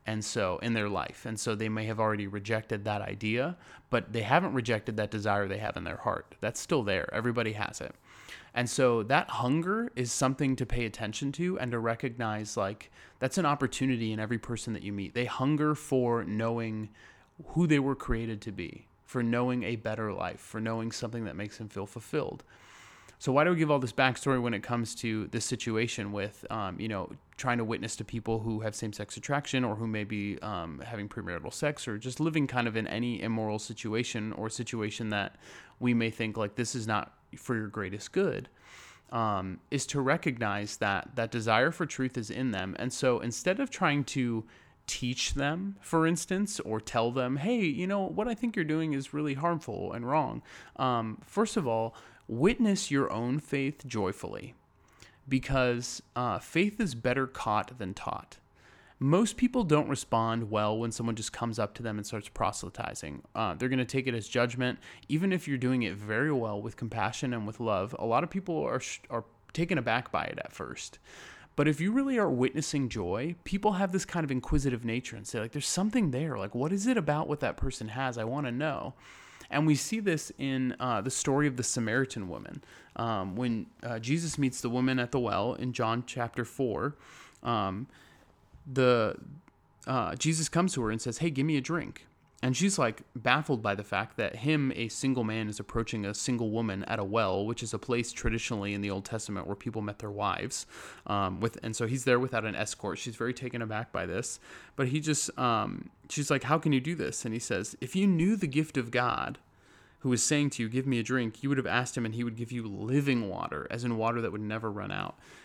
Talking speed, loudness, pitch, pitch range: 215 wpm, -31 LUFS, 120 Hz, 110-140 Hz